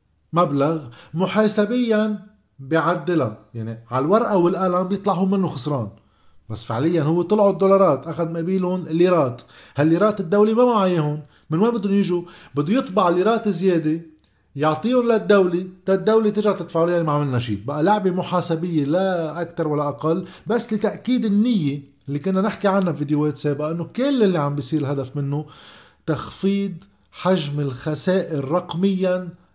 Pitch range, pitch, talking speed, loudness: 150-195 Hz, 175 Hz, 140 wpm, -21 LUFS